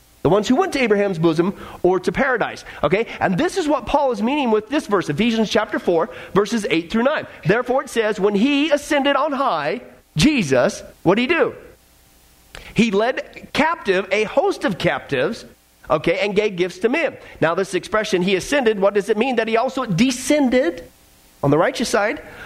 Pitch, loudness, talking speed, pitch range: 215 Hz, -19 LUFS, 190 wpm, 180-265 Hz